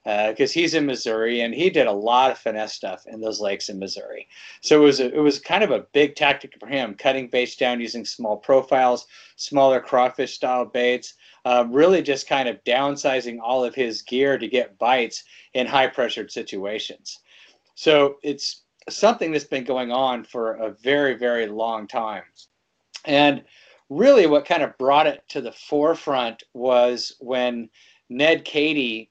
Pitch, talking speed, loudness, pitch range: 125 Hz, 175 wpm, -21 LUFS, 115-140 Hz